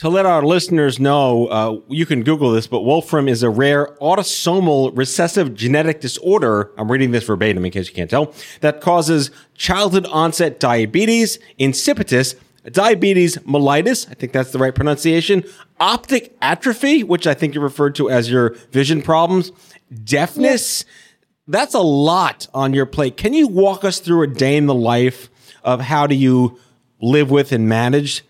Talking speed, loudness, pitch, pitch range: 170 wpm, -16 LUFS, 145 Hz, 125-175 Hz